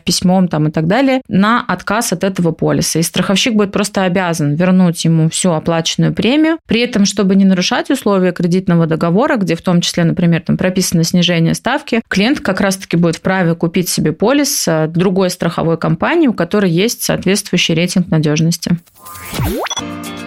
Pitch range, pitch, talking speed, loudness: 165-205 Hz, 185 Hz, 165 wpm, -13 LUFS